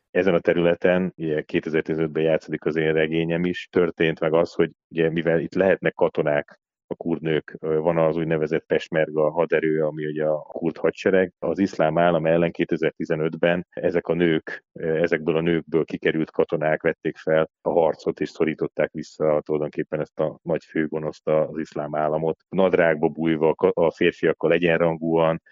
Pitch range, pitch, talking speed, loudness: 80-85 Hz, 80 Hz, 150 wpm, -23 LUFS